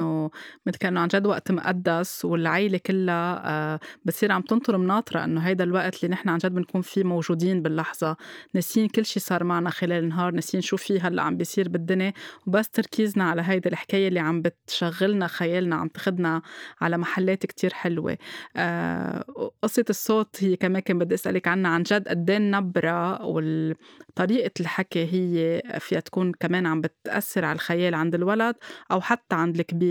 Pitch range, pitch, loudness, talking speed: 170-195 Hz, 180 Hz, -25 LUFS, 165 wpm